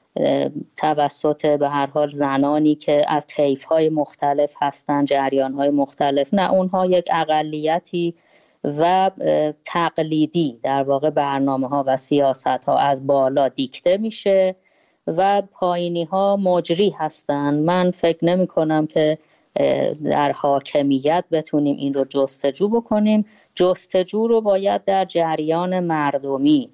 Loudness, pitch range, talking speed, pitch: -20 LUFS, 140-180 Hz, 115 wpm, 155 Hz